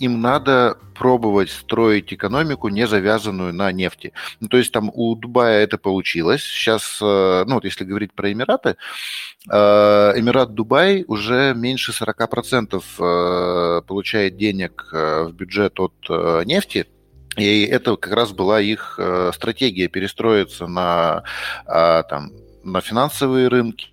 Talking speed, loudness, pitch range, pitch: 120 wpm, -18 LUFS, 95-120 Hz, 105 Hz